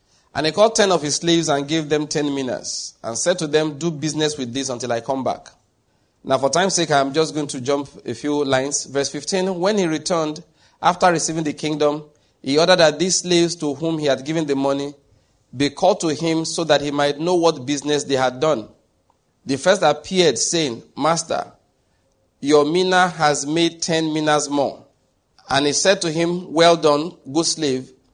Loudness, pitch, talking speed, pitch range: -19 LUFS, 150 Hz, 195 wpm, 140-165 Hz